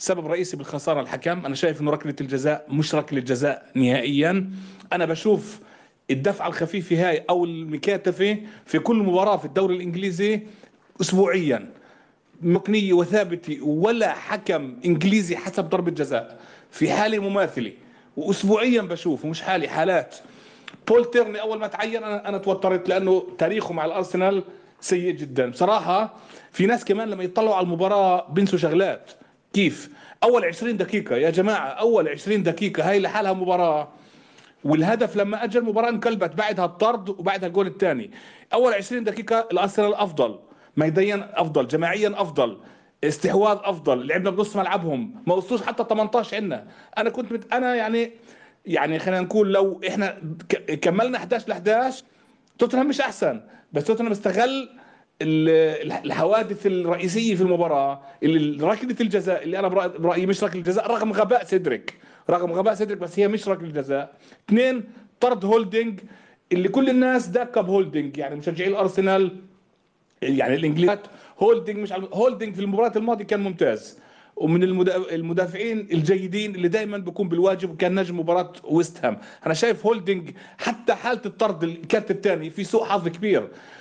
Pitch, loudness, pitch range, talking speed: 195 Hz, -23 LUFS, 175-220 Hz, 140 wpm